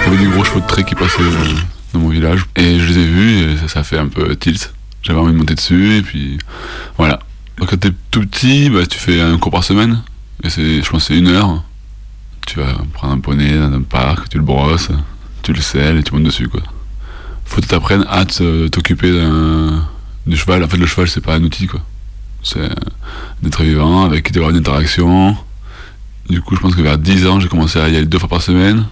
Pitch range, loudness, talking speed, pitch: 80-95 Hz, -13 LUFS, 235 wpm, 85 Hz